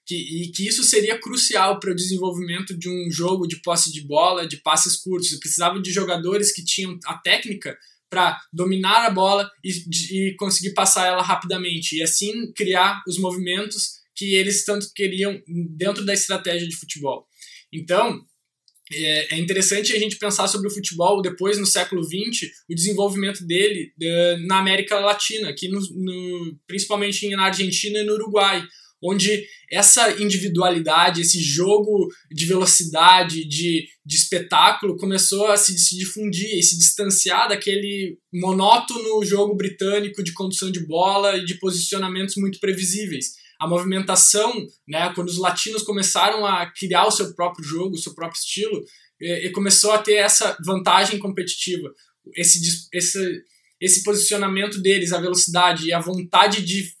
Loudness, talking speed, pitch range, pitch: -19 LUFS, 155 wpm, 175-200 Hz, 190 Hz